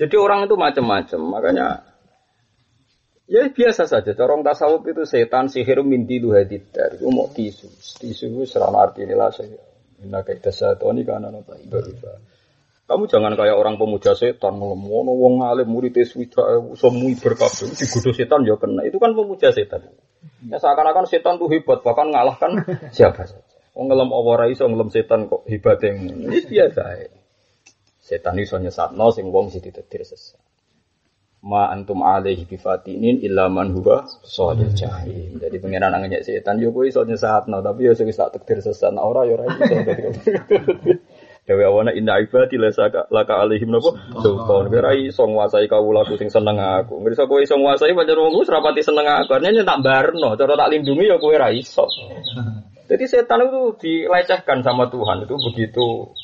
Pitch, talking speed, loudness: 185 Hz, 170 wpm, -18 LUFS